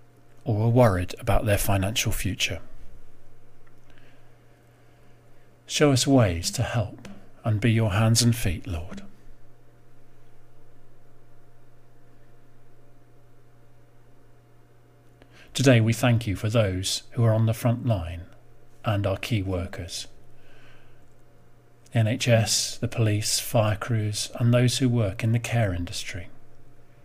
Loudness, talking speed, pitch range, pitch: -24 LUFS, 110 wpm, 110-120 Hz, 115 Hz